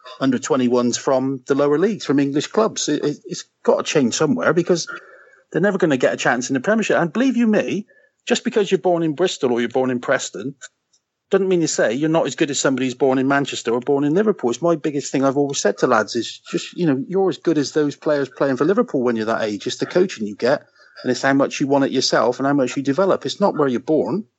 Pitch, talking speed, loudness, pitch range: 145 Hz, 270 wpm, -19 LUFS, 130-180 Hz